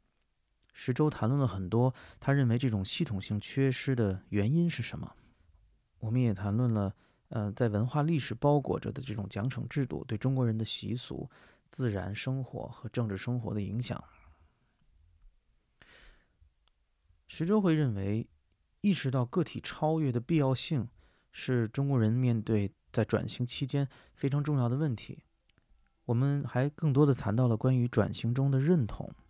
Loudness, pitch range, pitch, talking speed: -31 LUFS, 105-135 Hz, 120 Hz, 235 characters per minute